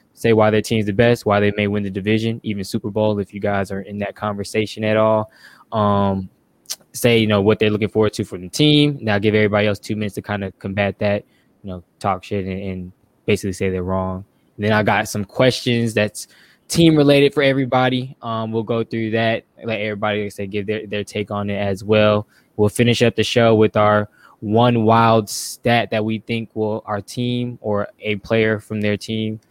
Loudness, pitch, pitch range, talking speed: -19 LUFS, 105 Hz, 105-115 Hz, 215 wpm